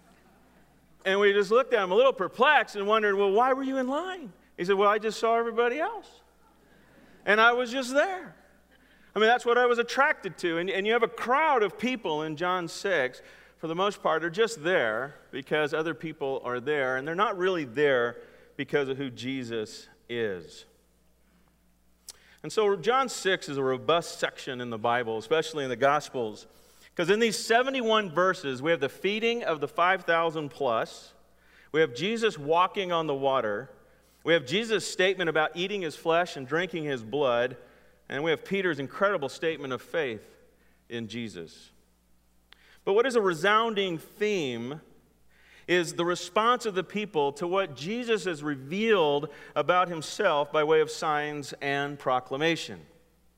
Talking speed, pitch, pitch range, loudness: 170 wpm, 170 Hz, 145-210 Hz, -27 LUFS